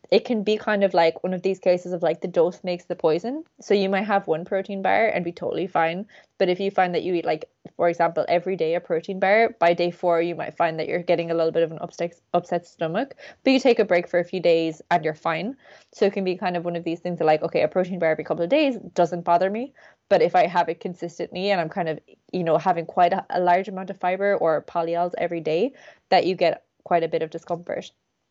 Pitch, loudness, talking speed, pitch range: 175 Hz, -23 LUFS, 270 wpm, 170-195 Hz